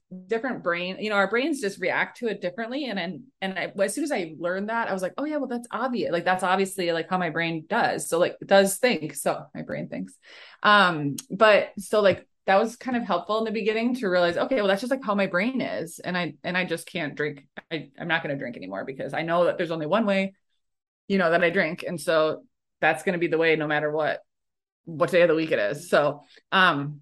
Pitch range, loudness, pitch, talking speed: 165-220 Hz, -25 LUFS, 185 Hz, 255 wpm